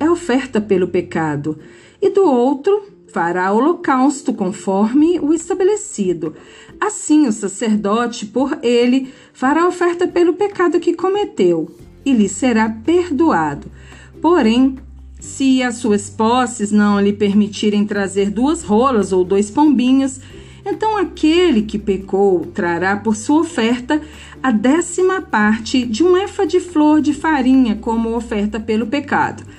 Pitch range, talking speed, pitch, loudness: 205-320 Hz, 130 wpm, 250 Hz, -16 LUFS